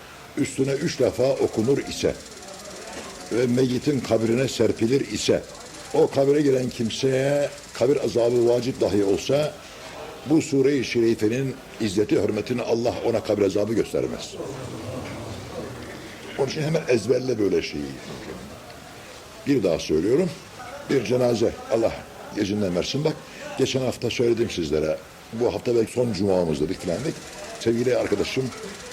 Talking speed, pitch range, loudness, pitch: 115 wpm, 105-130 Hz, -23 LUFS, 120 Hz